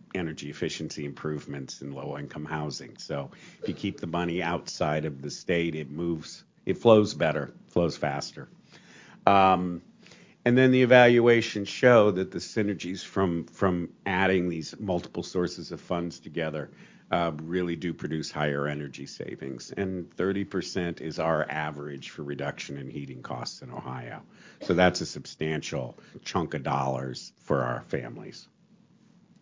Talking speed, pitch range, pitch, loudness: 145 wpm, 75-95 Hz, 85 Hz, -28 LUFS